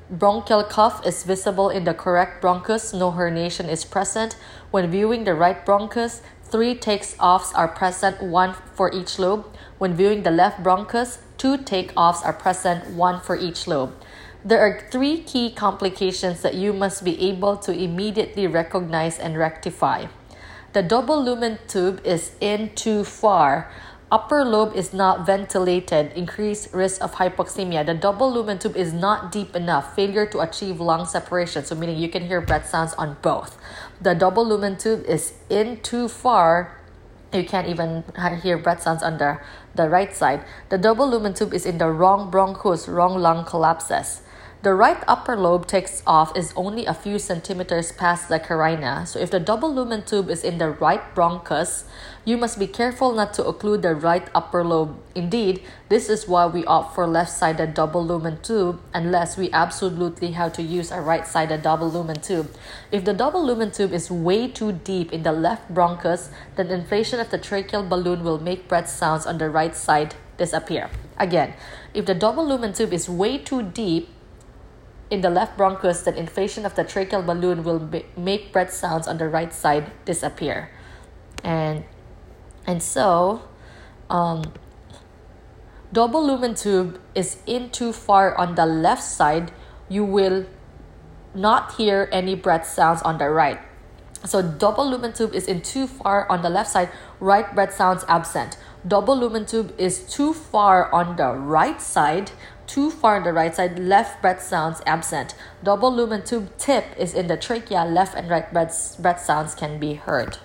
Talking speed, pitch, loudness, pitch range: 175 wpm, 185 Hz, -21 LUFS, 170-205 Hz